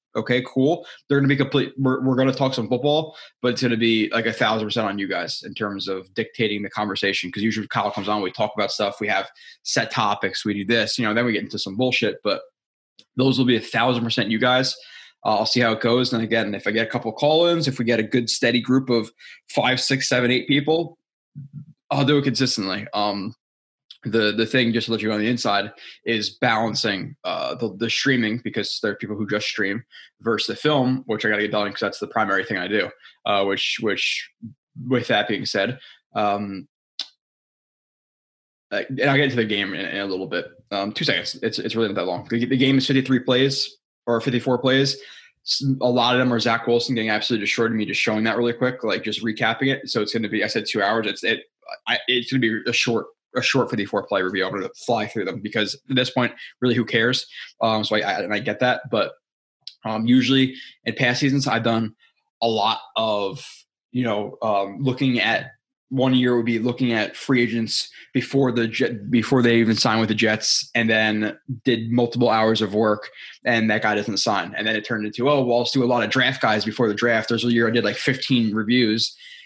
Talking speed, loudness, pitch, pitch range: 230 wpm, -21 LUFS, 120 Hz, 110-130 Hz